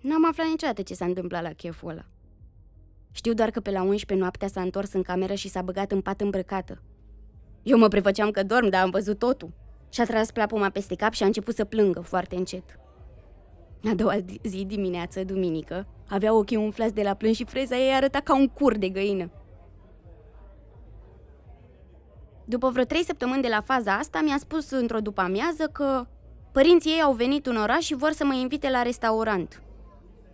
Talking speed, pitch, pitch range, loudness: 185 wpm, 205 Hz, 185-250 Hz, -25 LUFS